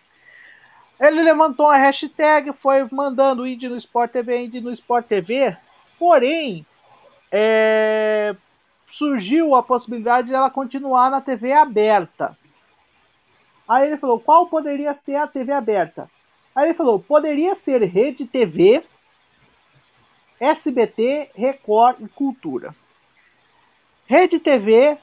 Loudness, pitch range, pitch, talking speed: -18 LUFS, 240-305 Hz, 270 Hz, 115 wpm